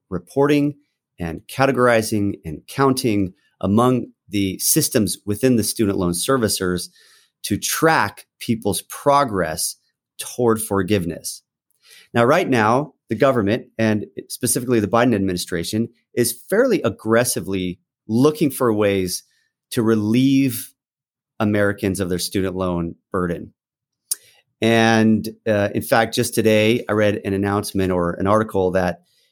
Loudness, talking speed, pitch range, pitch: -19 LUFS, 115 wpm, 95-125 Hz, 110 Hz